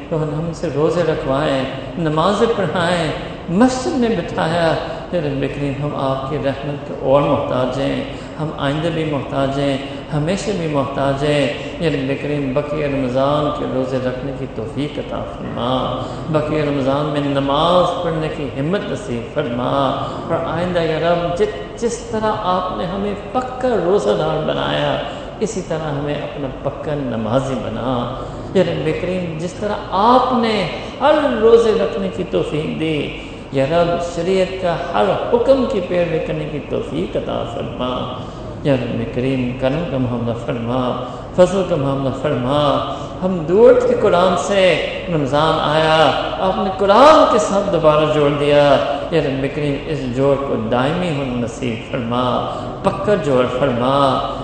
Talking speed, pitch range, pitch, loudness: 145 wpm, 135-180 Hz, 150 Hz, -18 LUFS